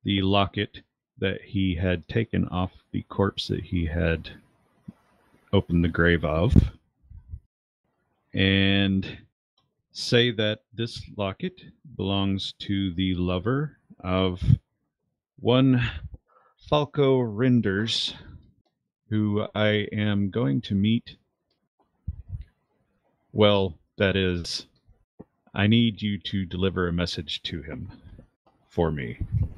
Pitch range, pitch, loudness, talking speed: 90-110 Hz, 100 Hz, -25 LUFS, 100 wpm